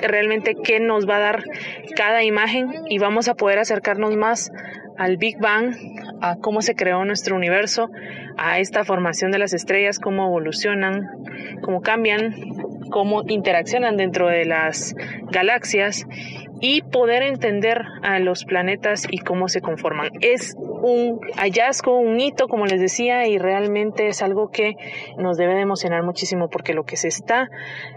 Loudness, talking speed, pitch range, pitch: -20 LUFS, 155 wpm, 185-225 Hz, 205 Hz